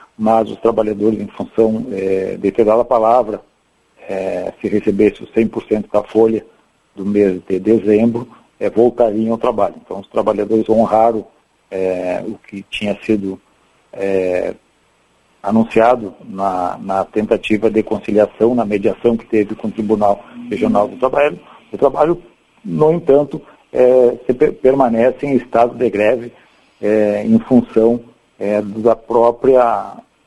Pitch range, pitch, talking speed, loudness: 105-115 Hz, 110 Hz, 135 wpm, -15 LUFS